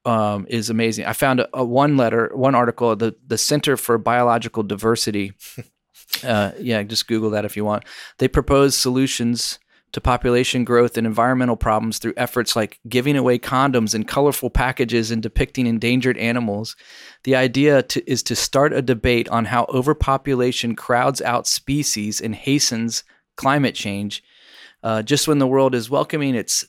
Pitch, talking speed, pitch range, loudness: 120 Hz, 165 wpm, 115-130 Hz, -19 LUFS